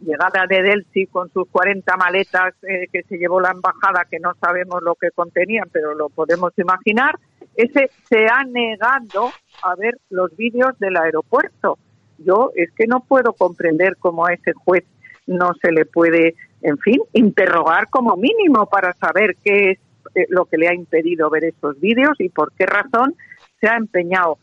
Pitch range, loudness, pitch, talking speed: 175-220 Hz, -17 LUFS, 185 Hz, 175 wpm